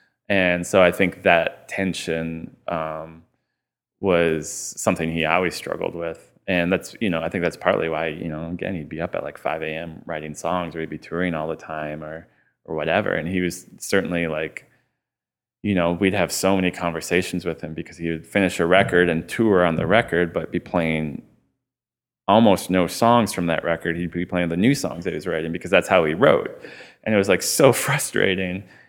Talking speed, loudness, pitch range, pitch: 205 wpm, -22 LUFS, 80-90 Hz, 85 Hz